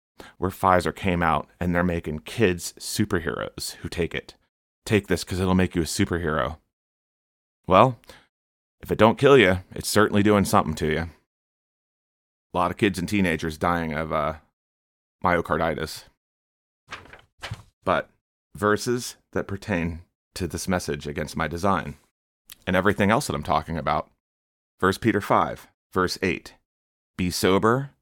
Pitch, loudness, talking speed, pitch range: 85 Hz, -24 LUFS, 140 wpm, 75-95 Hz